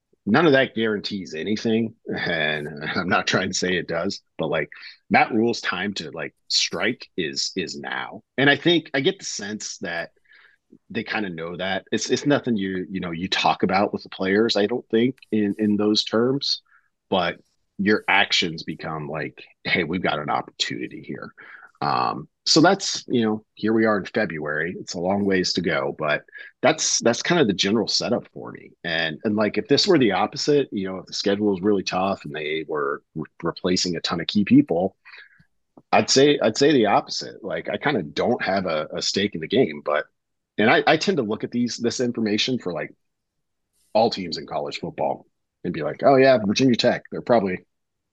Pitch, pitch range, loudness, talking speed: 110 Hz, 100-130 Hz, -22 LUFS, 205 wpm